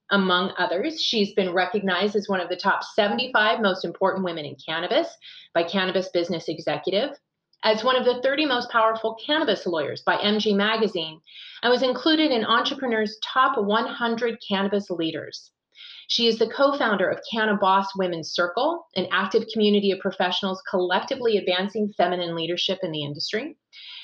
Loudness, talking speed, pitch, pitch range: -23 LUFS, 155 wpm, 205 Hz, 185-230 Hz